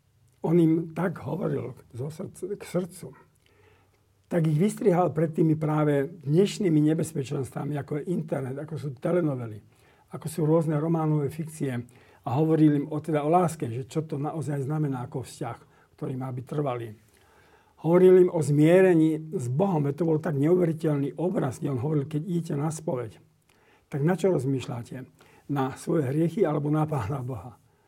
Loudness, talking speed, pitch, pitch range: -26 LUFS, 155 wpm, 150 Hz, 135-170 Hz